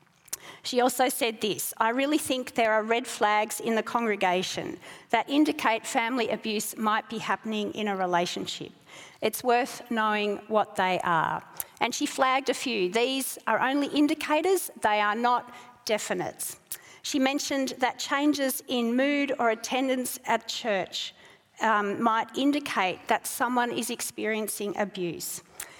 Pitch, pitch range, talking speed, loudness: 230 Hz, 210-260 Hz, 140 wpm, -27 LUFS